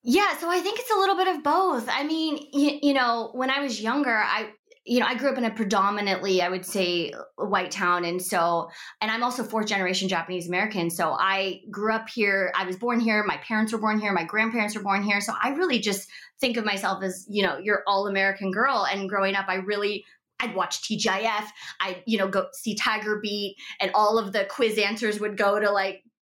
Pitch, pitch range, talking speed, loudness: 210 Hz, 195-235 Hz, 225 wpm, -25 LUFS